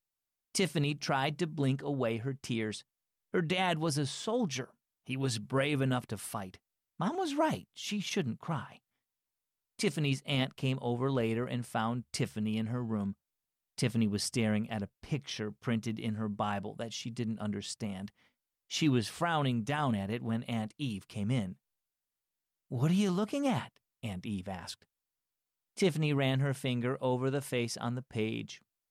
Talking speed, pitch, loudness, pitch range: 160 wpm, 125 Hz, -34 LUFS, 110-145 Hz